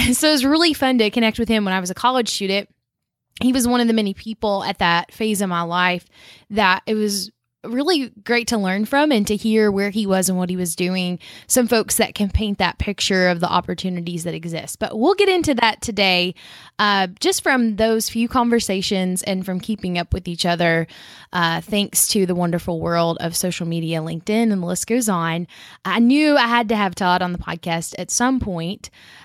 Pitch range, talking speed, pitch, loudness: 180-230 Hz, 215 wpm, 200 Hz, -19 LUFS